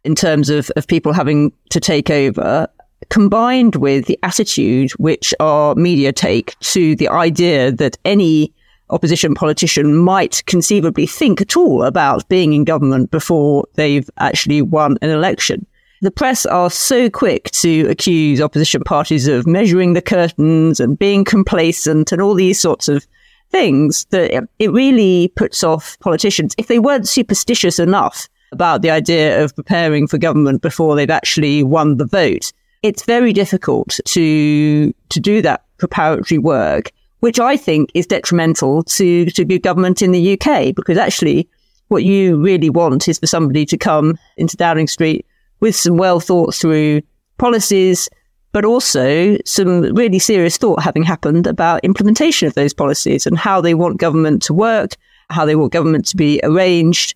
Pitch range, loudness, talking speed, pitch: 155-195 Hz, -13 LUFS, 160 wpm, 170 Hz